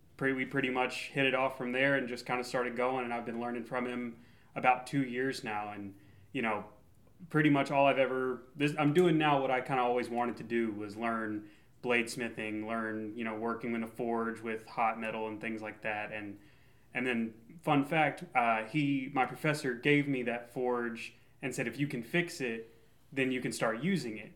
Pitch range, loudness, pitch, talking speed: 115-135 Hz, -33 LUFS, 125 Hz, 215 wpm